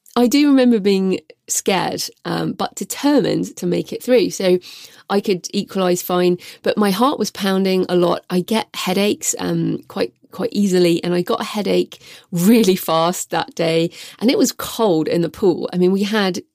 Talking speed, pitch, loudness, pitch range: 185 wpm, 190 Hz, -18 LUFS, 175-225 Hz